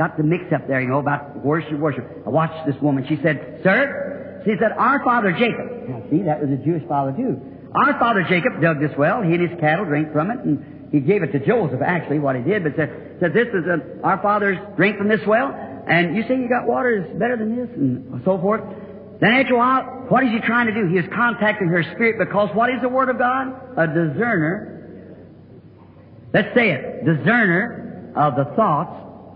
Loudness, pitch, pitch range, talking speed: -19 LUFS, 180 Hz, 150-230 Hz, 225 wpm